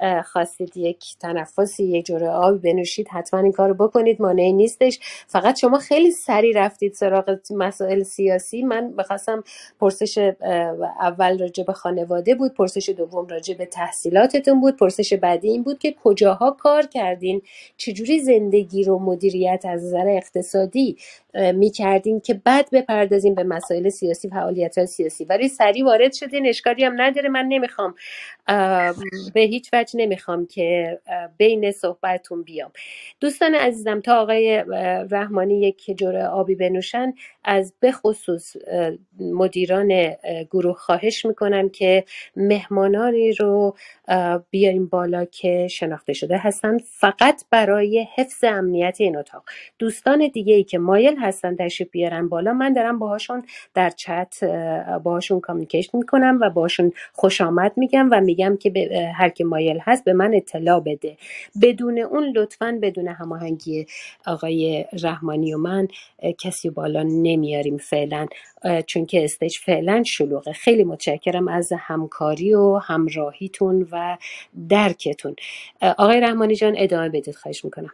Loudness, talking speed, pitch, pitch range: -20 LUFS, 130 wpm, 195 Hz, 175-220 Hz